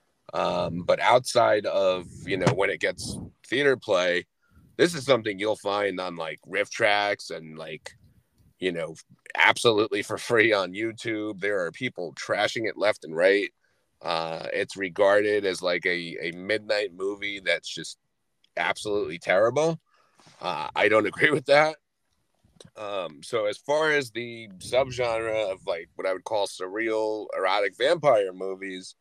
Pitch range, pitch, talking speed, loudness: 95-115 Hz, 105 Hz, 150 wpm, -25 LUFS